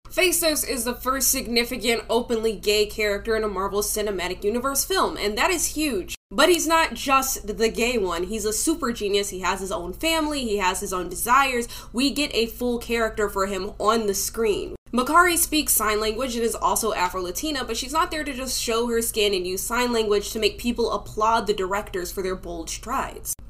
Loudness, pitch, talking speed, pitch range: -23 LUFS, 225 Hz, 205 wpm, 205-270 Hz